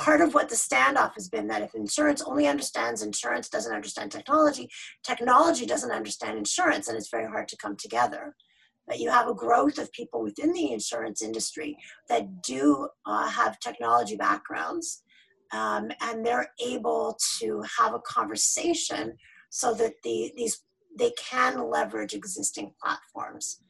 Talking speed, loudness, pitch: 155 wpm, -27 LUFS, 290 Hz